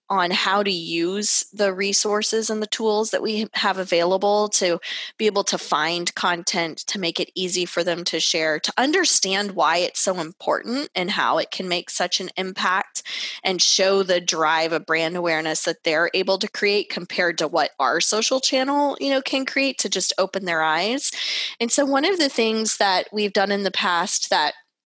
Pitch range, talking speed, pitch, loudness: 175-215 Hz, 195 wpm, 190 Hz, -21 LUFS